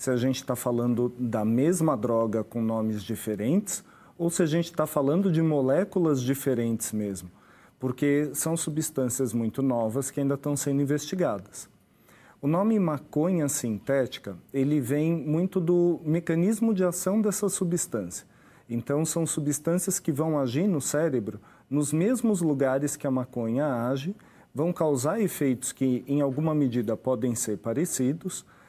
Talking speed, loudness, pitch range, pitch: 145 wpm, -27 LUFS, 125-170 Hz, 145 Hz